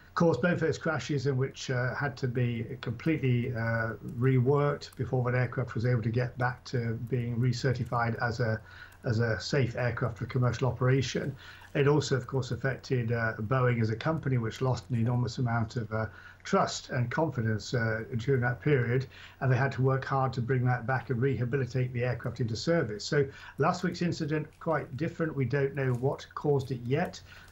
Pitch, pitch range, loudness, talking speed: 130 Hz, 120-140 Hz, -30 LUFS, 190 wpm